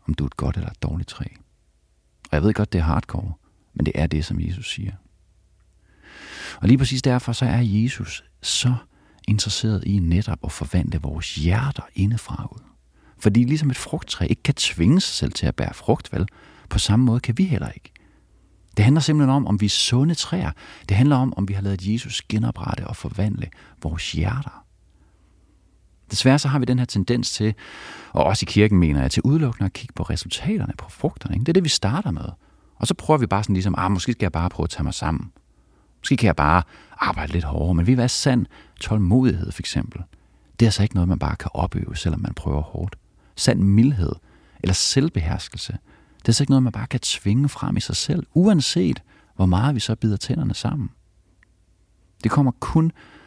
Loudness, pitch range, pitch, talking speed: -22 LUFS, 90-125 Hz, 105 Hz, 205 wpm